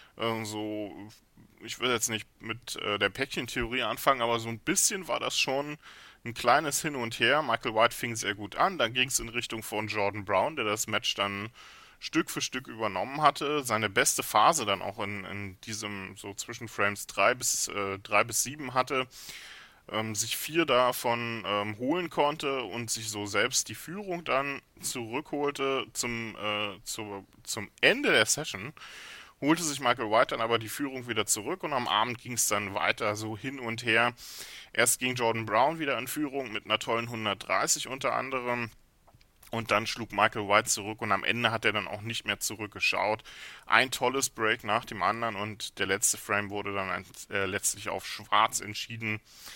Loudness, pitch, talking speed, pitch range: -29 LUFS, 115 Hz, 180 wpm, 105-125 Hz